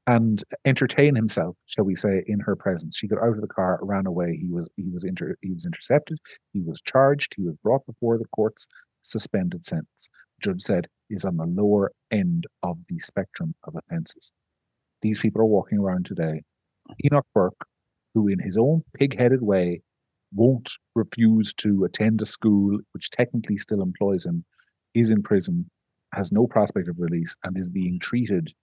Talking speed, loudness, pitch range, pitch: 180 wpm, -24 LUFS, 95-140 Hz, 110 Hz